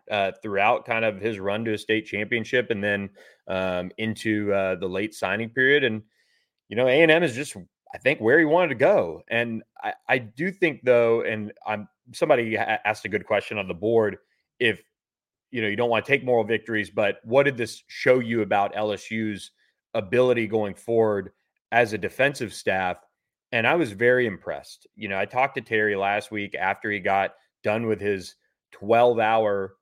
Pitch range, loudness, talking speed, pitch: 100-120 Hz, -24 LUFS, 190 wpm, 110 Hz